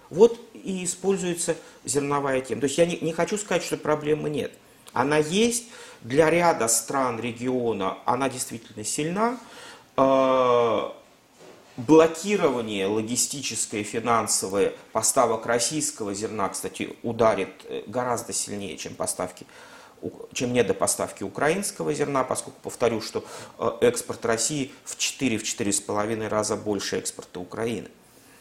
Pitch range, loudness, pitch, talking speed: 115-170 Hz, -25 LUFS, 140 Hz, 110 wpm